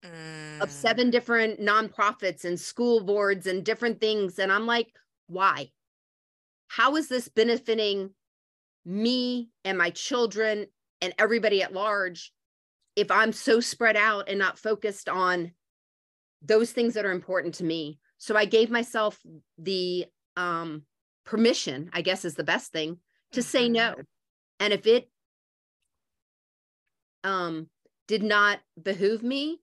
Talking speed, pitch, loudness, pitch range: 135 wpm, 200 Hz, -26 LUFS, 170-225 Hz